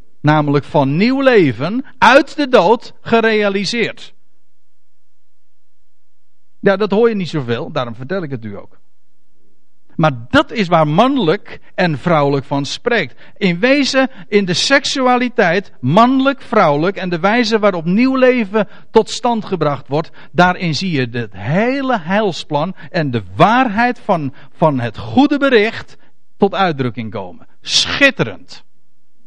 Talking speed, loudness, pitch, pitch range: 130 wpm, -14 LUFS, 180 Hz, 140-230 Hz